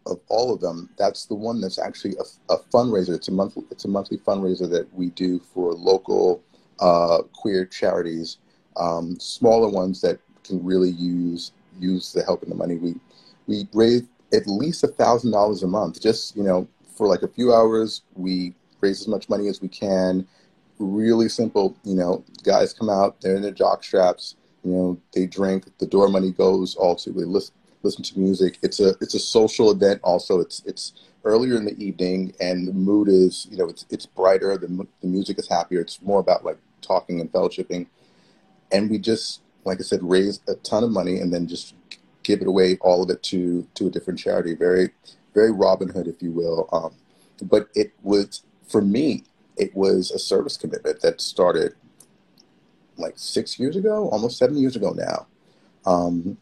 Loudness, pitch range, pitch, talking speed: -22 LUFS, 90-105 Hz, 95 Hz, 195 wpm